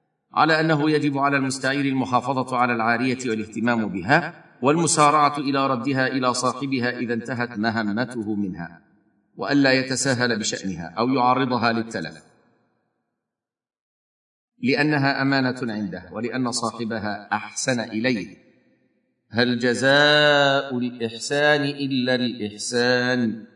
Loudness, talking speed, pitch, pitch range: -22 LUFS, 95 wpm, 125 Hz, 115-135 Hz